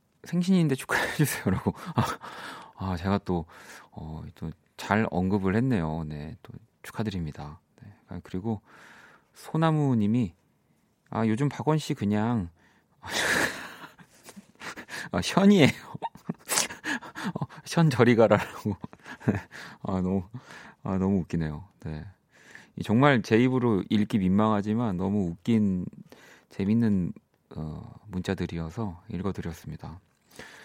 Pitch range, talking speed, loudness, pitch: 90-120 Hz, 215 characters per minute, -27 LUFS, 105 Hz